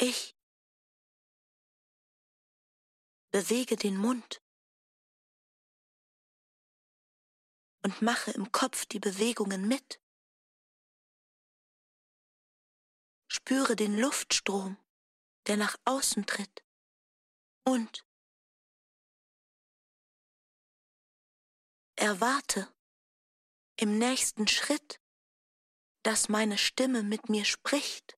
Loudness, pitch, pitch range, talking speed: -30 LUFS, 225 Hz, 210-255 Hz, 60 wpm